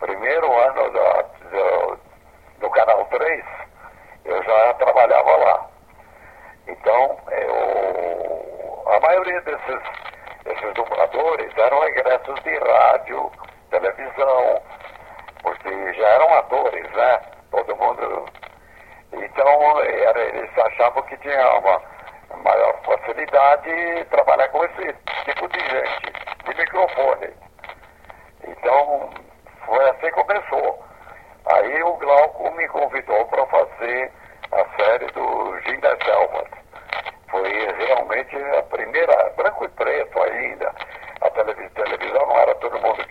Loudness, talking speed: -19 LUFS, 115 wpm